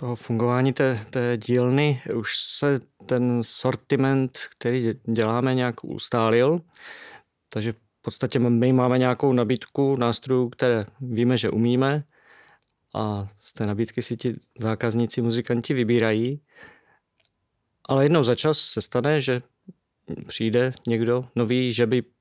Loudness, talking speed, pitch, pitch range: -23 LUFS, 125 wpm, 125 Hz, 115-130 Hz